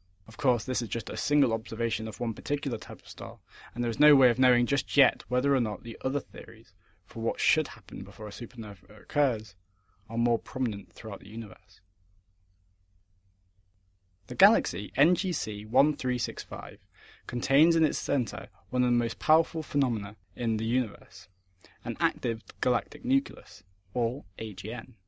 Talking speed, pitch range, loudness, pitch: 160 wpm, 100-130 Hz, -28 LUFS, 115 Hz